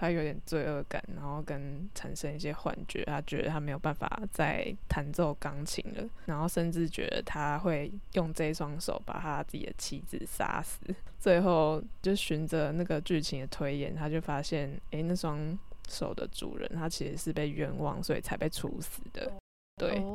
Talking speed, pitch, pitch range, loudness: 260 characters per minute, 155 Hz, 150-175 Hz, -35 LUFS